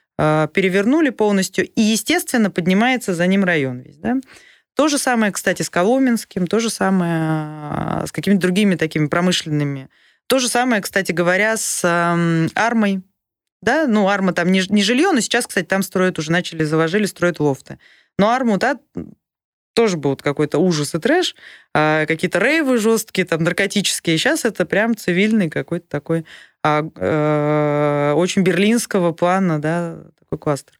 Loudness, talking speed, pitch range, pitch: -18 LUFS, 145 wpm, 160-220 Hz, 185 Hz